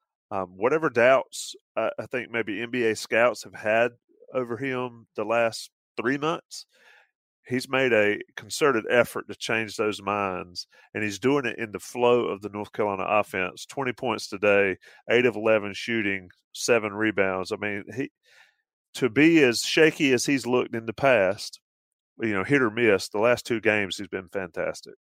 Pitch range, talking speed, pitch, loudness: 105-125 Hz, 175 wpm, 115 Hz, -25 LUFS